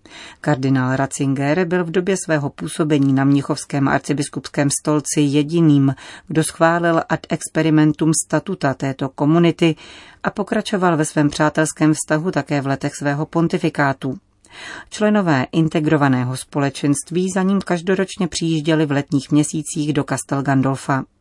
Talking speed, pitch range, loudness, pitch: 120 wpm, 140-170 Hz, -18 LUFS, 155 Hz